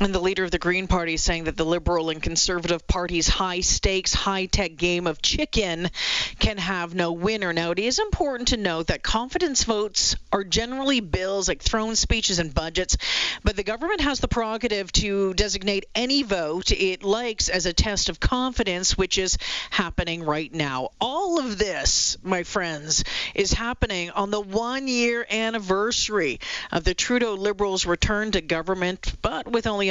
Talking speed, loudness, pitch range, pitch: 175 wpm, -23 LUFS, 175-225 Hz, 195 Hz